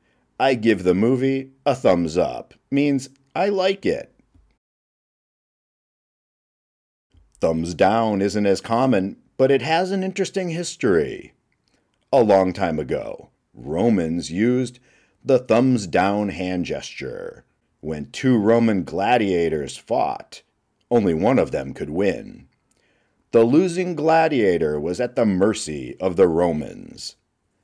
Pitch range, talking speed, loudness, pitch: 90-140 Hz, 115 wpm, -21 LUFS, 115 Hz